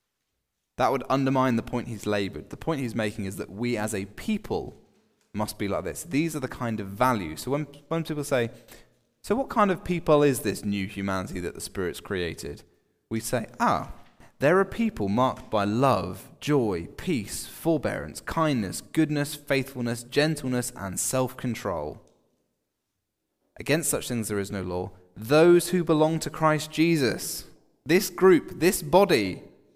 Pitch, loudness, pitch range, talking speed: 130 Hz, -26 LUFS, 105-155 Hz, 160 wpm